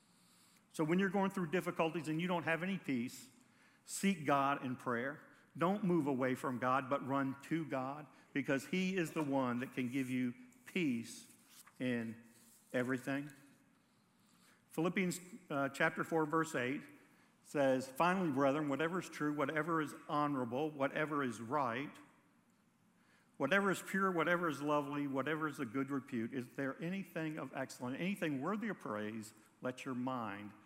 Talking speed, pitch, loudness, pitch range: 155 wpm, 150 Hz, -38 LUFS, 135-175 Hz